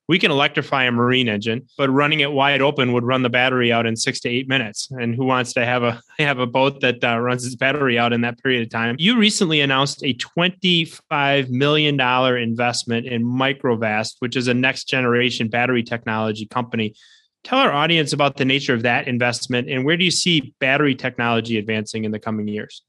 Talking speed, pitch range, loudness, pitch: 205 wpm, 120-140 Hz, -19 LUFS, 125 Hz